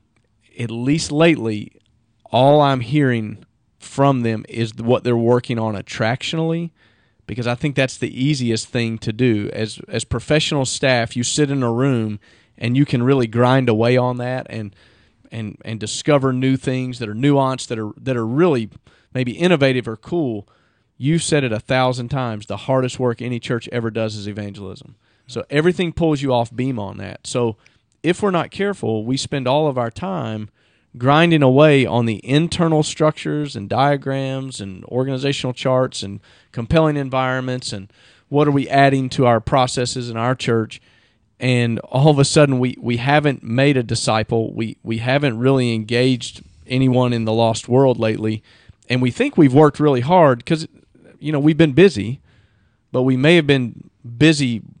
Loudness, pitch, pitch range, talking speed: -18 LUFS, 125 Hz, 115-140 Hz, 175 wpm